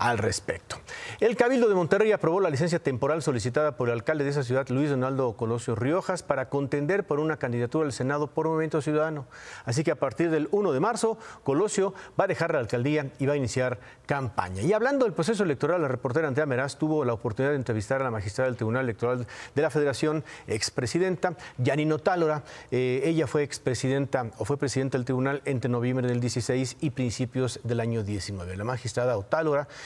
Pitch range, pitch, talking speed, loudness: 125-160 Hz, 140 Hz, 195 wpm, -27 LUFS